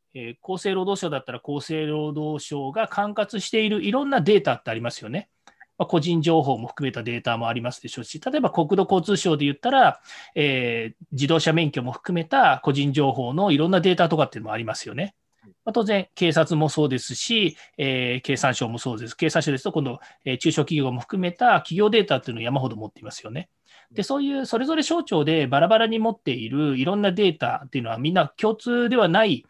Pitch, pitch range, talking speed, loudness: 155 Hz, 130-195 Hz, 435 characters per minute, -23 LUFS